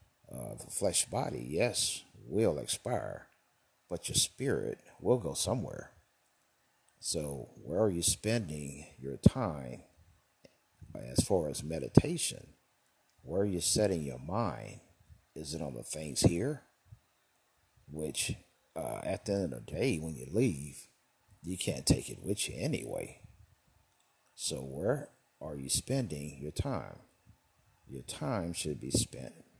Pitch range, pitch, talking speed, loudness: 70-100 Hz, 80 Hz, 135 wpm, -34 LUFS